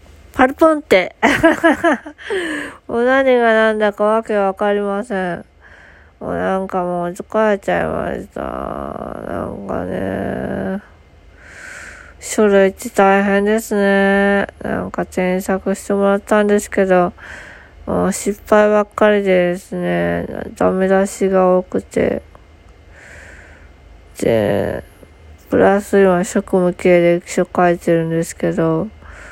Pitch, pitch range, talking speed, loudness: 195 Hz, 175-210 Hz, 210 characters per minute, -16 LUFS